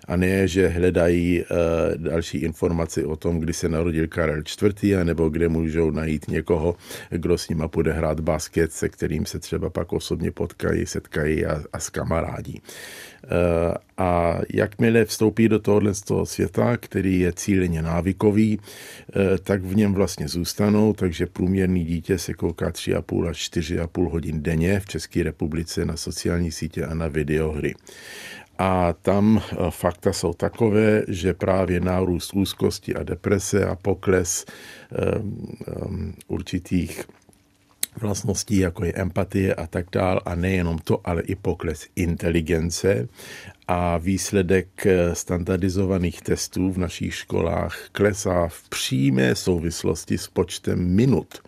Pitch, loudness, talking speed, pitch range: 90 Hz, -23 LUFS, 140 wpm, 85-95 Hz